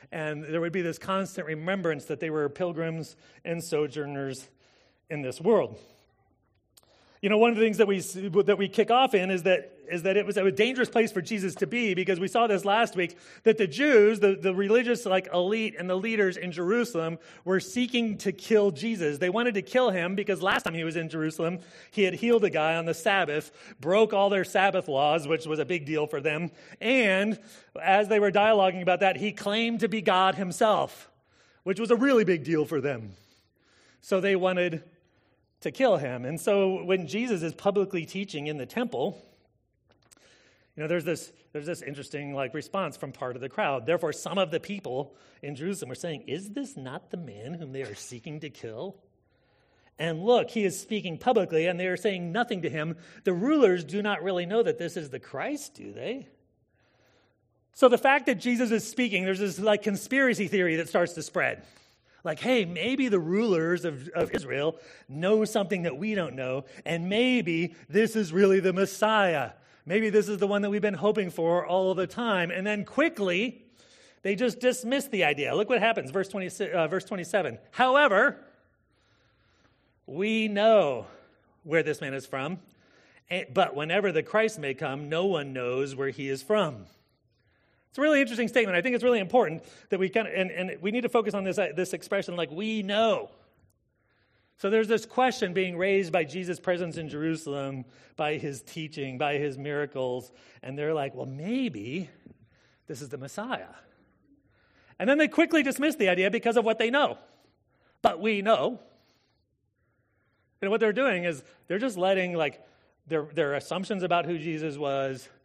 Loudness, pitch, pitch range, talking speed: -27 LUFS, 185 Hz, 155-210 Hz, 190 wpm